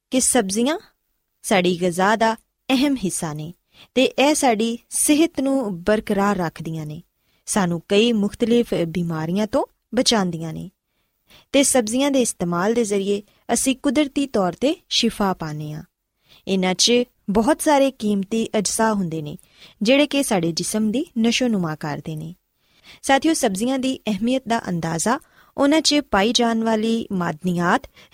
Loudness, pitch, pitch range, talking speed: -20 LUFS, 220 Hz, 180-260 Hz, 135 wpm